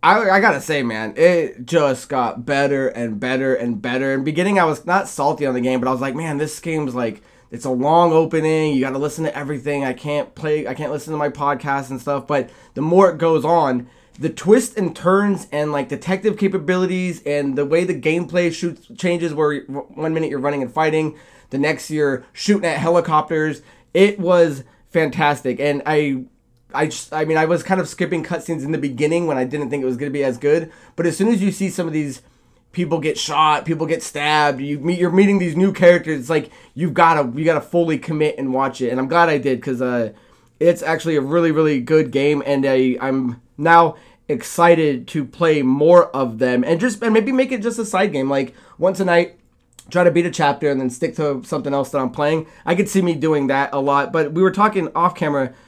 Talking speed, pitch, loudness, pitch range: 230 wpm, 155 Hz, -18 LUFS, 140-170 Hz